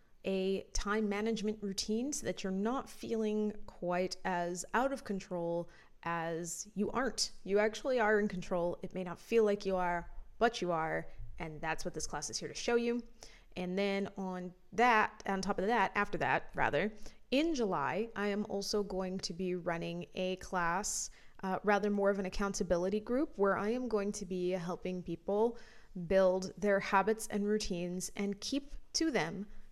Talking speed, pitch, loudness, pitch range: 180 wpm, 195 Hz, -35 LUFS, 180-215 Hz